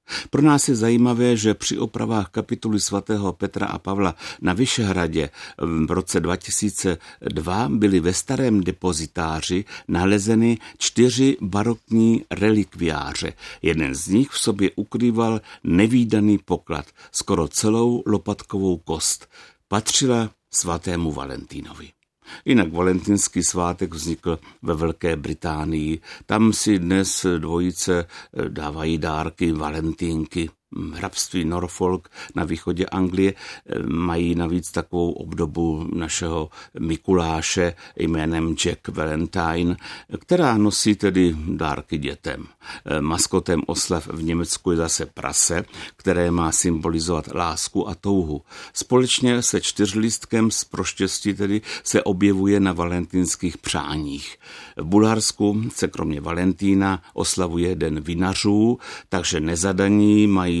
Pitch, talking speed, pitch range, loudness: 90 Hz, 105 wpm, 85-105 Hz, -21 LUFS